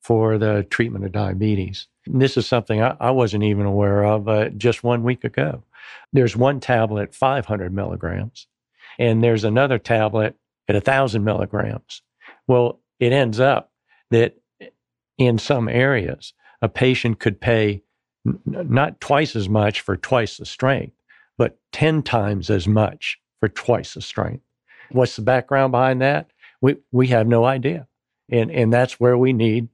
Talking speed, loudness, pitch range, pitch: 160 wpm, -20 LUFS, 105-130 Hz, 115 Hz